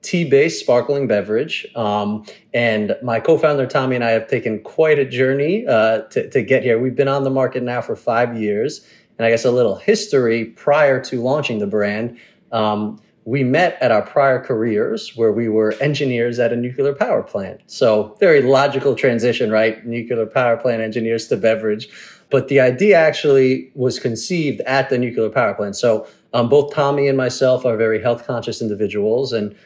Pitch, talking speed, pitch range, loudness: 120 Hz, 180 wpm, 110-135 Hz, -17 LUFS